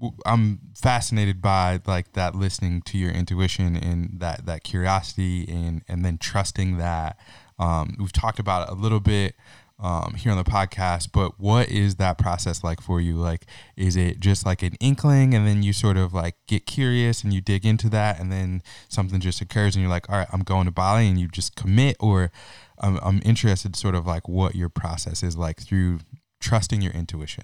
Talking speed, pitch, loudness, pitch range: 205 wpm, 95 Hz, -23 LUFS, 90-105 Hz